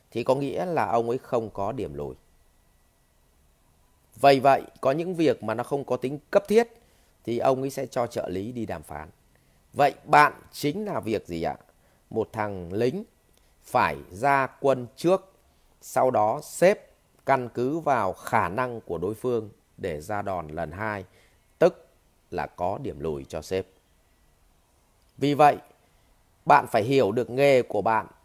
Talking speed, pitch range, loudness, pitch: 165 wpm, 85-130 Hz, -25 LUFS, 110 Hz